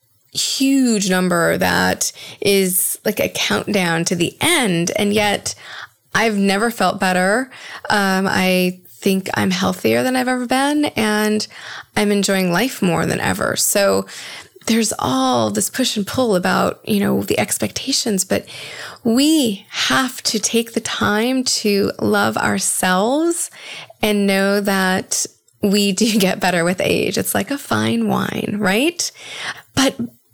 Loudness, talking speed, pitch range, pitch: -17 LUFS, 140 wpm, 185-230 Hz, 205 Hz